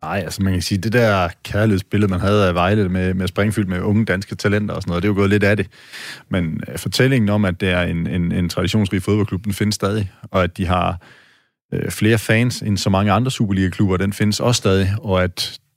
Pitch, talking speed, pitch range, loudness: 100 Hz, 230 wpm, 95-105 Hz, -18 LUFS